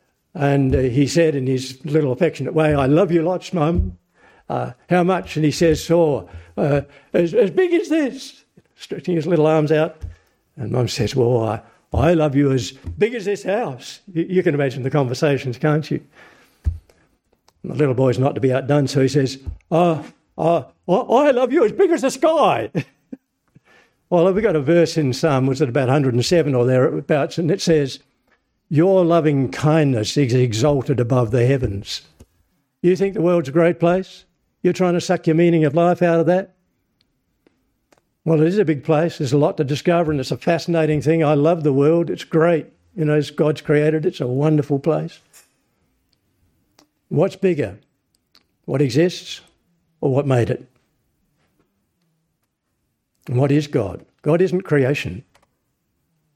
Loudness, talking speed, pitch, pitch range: -18 LUFS, 175 wpm, 155 Hz, 135-170 Hz